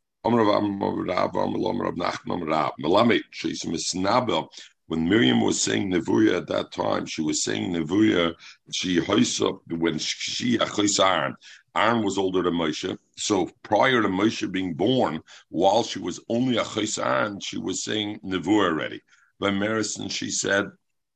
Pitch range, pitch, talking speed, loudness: 85-105 Hz, 100 Hz, 115 wpm, -24 LUFS